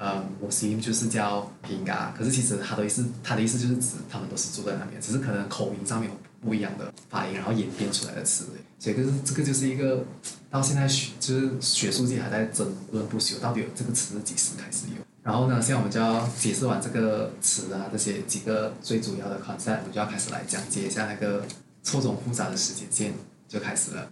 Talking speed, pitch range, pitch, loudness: 375 characters per minute, 105-125 Hz, 115 Hz, -27 LUFS